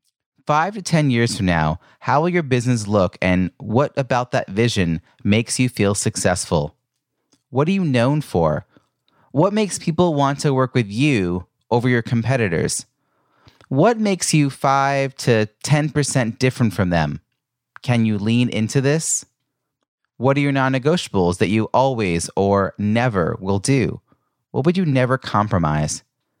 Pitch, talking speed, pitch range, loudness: 125 Hz, 150 wpm, 105-140 Hz, -19 LUFS